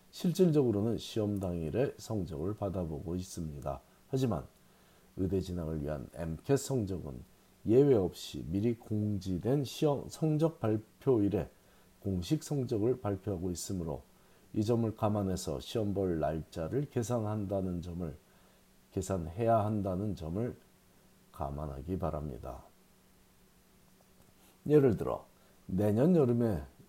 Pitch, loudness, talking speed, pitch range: 100 Hz, -33 LUFS, 255 characters per minute, 85-115 Hz